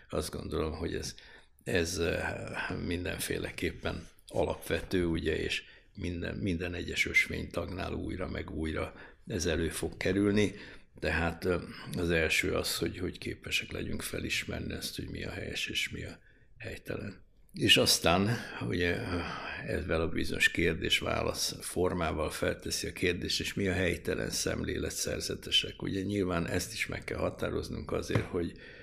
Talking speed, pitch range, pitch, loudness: 135 wpm, 85-100 Hz, 90 Hz, -32 LUFS